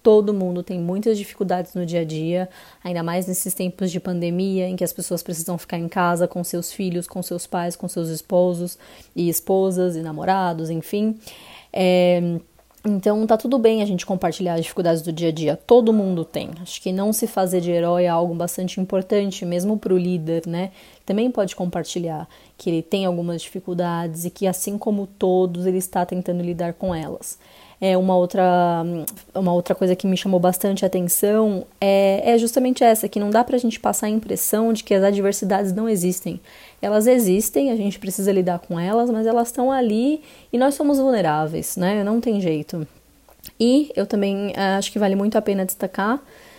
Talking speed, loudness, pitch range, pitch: 190 wpm, -21 LUFS, 175-210 Hz, 185 Hz